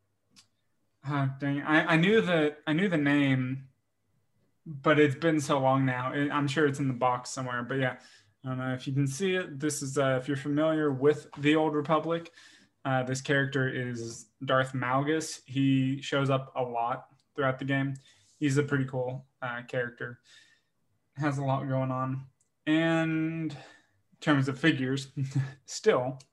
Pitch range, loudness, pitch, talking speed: 130-150 Hz, -29 LUFS, 135 Hz, 170 wpm